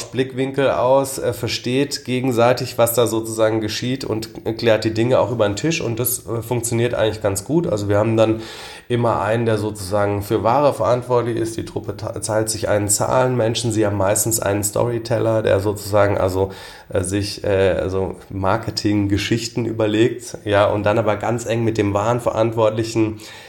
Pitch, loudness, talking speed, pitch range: 110 Hz, -19 LUFS, 170 wpm, 105-120 Hz